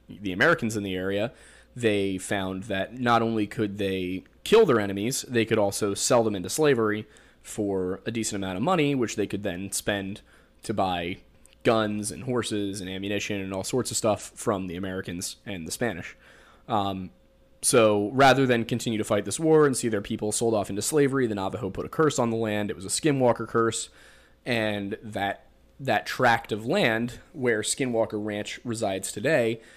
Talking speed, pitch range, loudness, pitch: 185 wpm, 100-115 Hz, -26 LUFS, 105 Hz